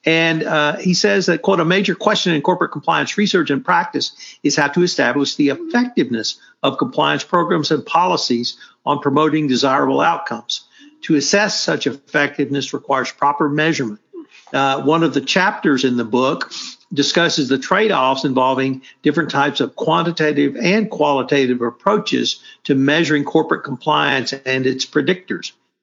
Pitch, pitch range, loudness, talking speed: 150 Hz, 140-175 Hz, -17 LUFS, 145 wpm